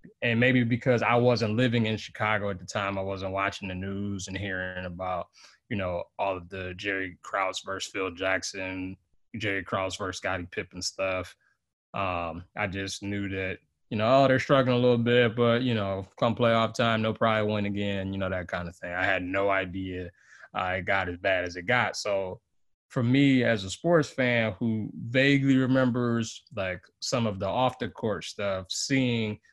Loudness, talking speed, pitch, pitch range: -27 LUFS, 190 wpm, 100 Hz, 95-120 Hz